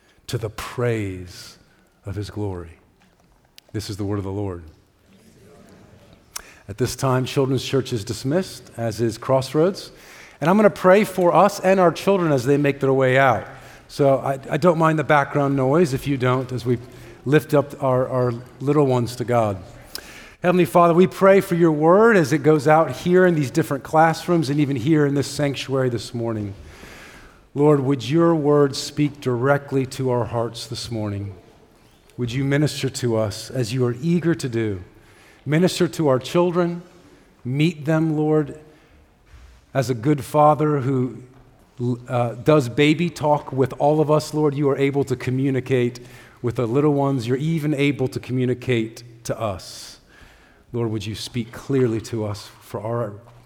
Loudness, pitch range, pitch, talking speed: -20 LUFS, 120-150 Hz, 135 Hz, 170 wpm